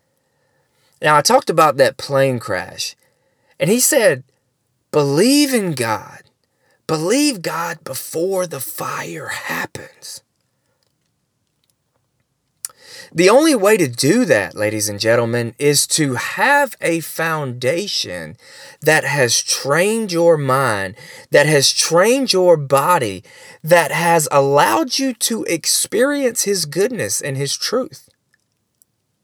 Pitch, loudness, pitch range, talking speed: 150 Hz, -16 LUFS, 130-185 Hz, 110 wpm